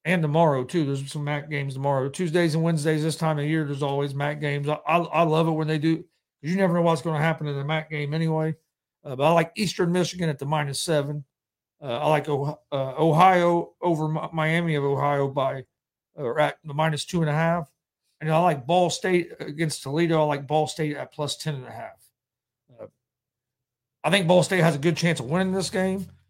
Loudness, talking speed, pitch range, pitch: -24 LUFS, 225 wpm, 145-170 Hz, 155 Hz